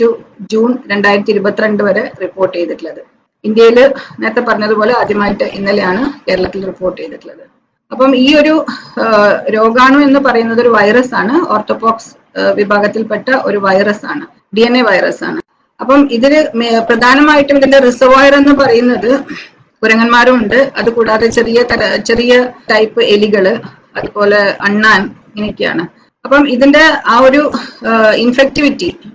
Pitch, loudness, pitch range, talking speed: 235 Hz, -9 LUFS, 210-265 Hz, 115 wpm